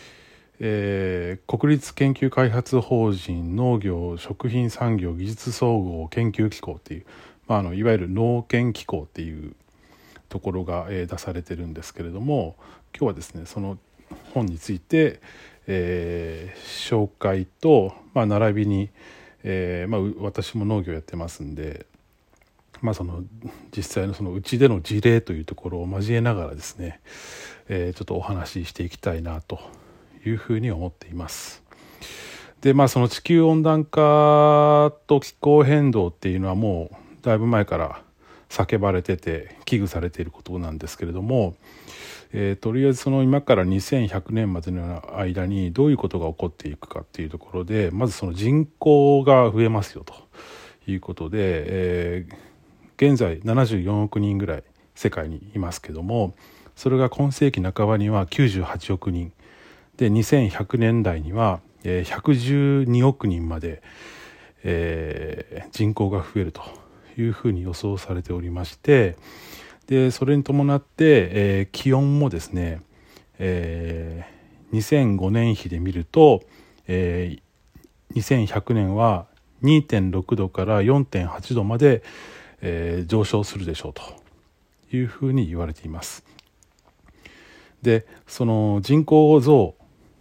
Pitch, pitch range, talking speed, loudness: 100 Hz, 90-120 Hz, 260 characters per minute, -22 LUFS